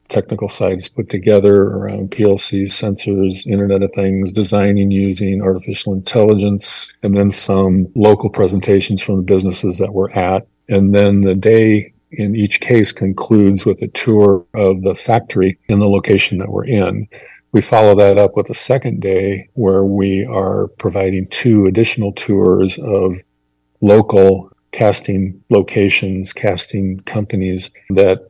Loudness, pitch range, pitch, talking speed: -13 LUFS, 95-105 Hz, 100 Hz, 140 wpm